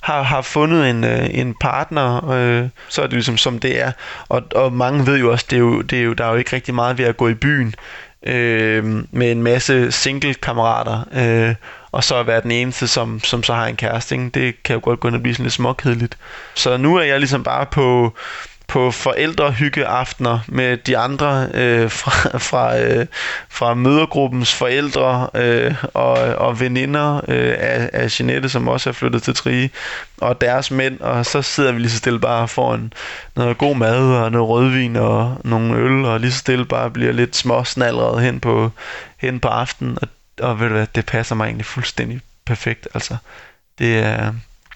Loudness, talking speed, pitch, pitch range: -17 LUFS, 200 wpm, 120 Hz, 115-130 Hz